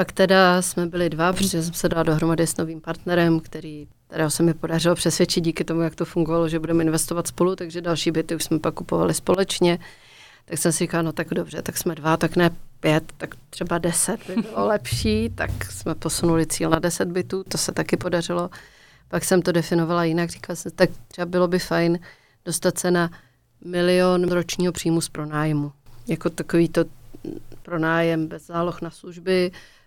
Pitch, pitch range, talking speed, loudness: 170 Hz, 160-175 Hz, 190 wpm, -22 LUFS